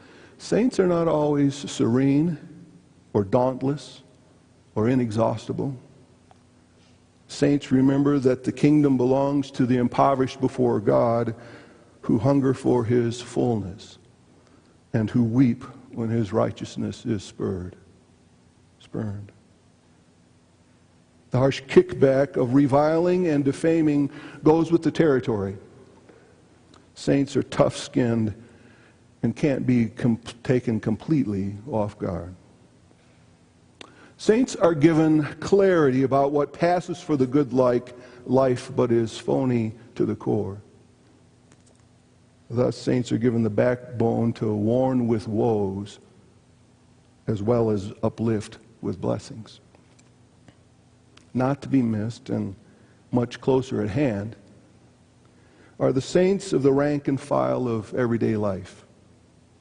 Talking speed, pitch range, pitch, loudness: 110 wpm, 110-140 Hz, 125 Hz, -23 LUFS